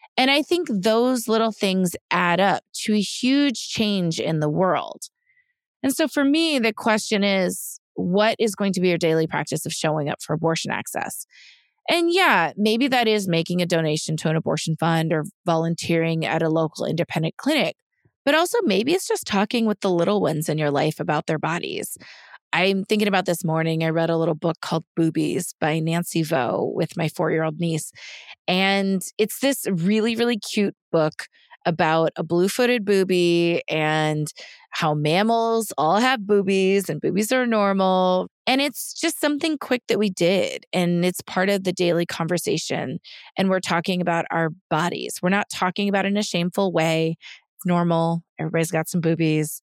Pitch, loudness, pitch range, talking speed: 180 Hz, -22 LUFS, 165-215 Hz, 180 wpm